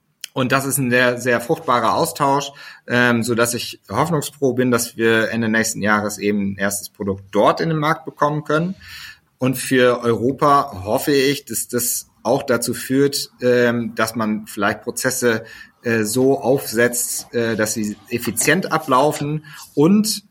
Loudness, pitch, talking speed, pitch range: -19 LUFS, 120 Hz, 155 wpm, 115-140 Hz